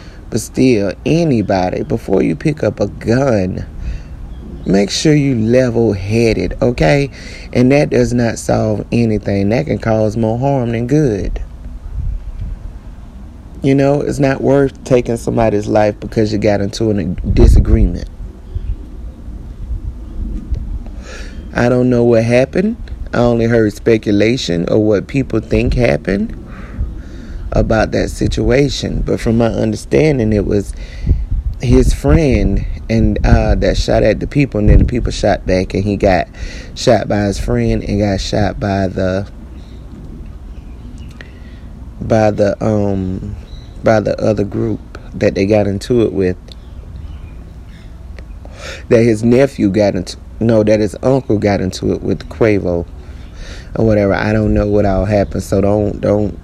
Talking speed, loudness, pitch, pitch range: 140 wpm, -14 LUFS, 105 Hz, 90-115 Hz